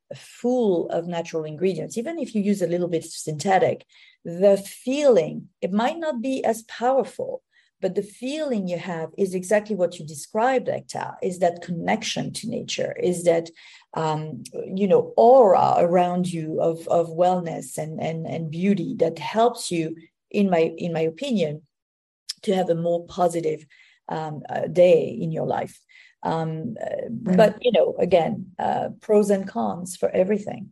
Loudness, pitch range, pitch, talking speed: -23 LUFS, 165-235 Hz, 190 Hz, 160 wpm